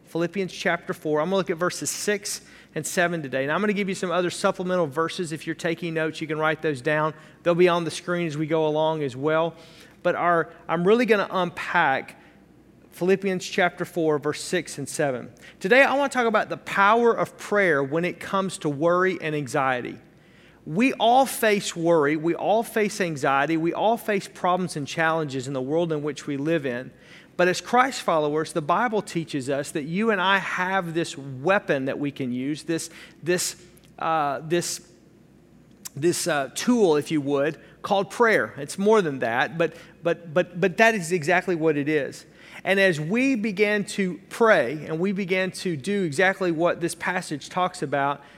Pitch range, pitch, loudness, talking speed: 155-195 Hz, 175 Hz, -24 LUFS, 195 wpm